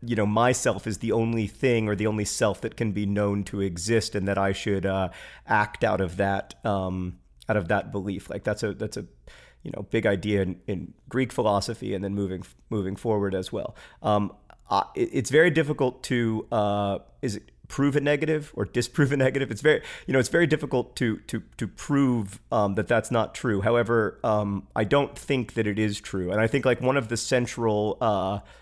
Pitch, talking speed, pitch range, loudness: 110 Hz, 210 wpm, 100-125 Hz, -26 LUFS